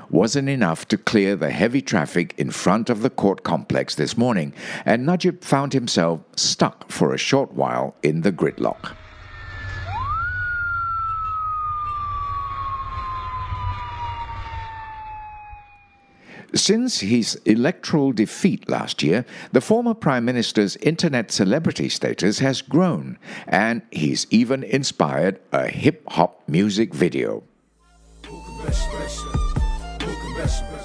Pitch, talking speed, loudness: 140 Hz, 100 wpm, -22 LUFS